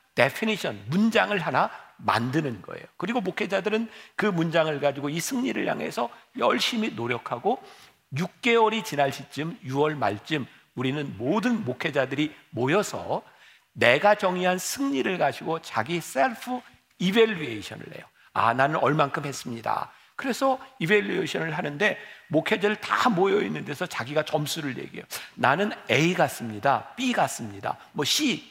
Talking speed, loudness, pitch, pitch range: 315 characters per minute, -26 LUFS, 165 Hz, 145-215 Hz